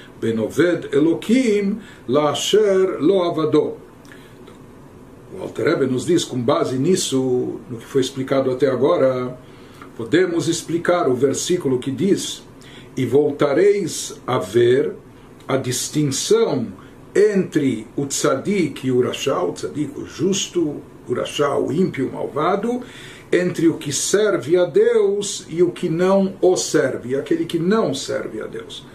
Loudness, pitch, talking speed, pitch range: -19 LUFS, 165 Hz, 130 wpm, 135-195 Hz